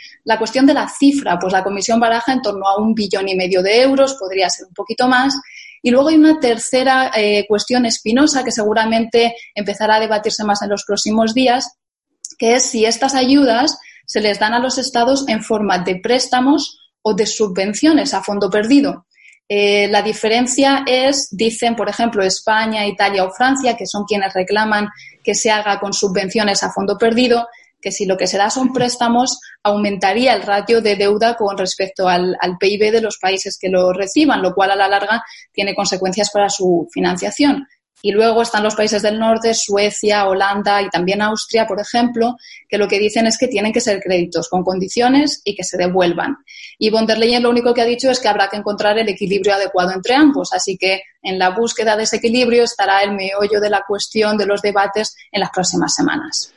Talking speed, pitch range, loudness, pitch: 200 wpm, 200-240 Hz, -15 LUFS, 215 Hz